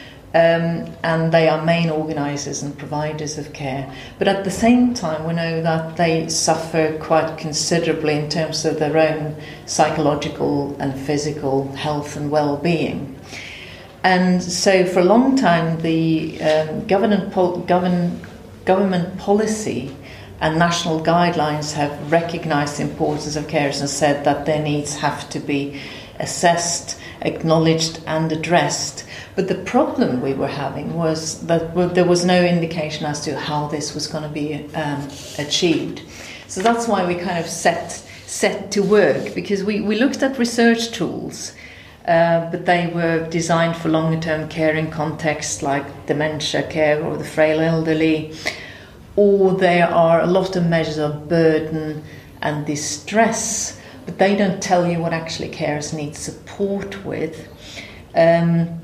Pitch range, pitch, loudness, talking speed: 150-175 Hz, 160 Hz, -19 LUFS, 150 wpm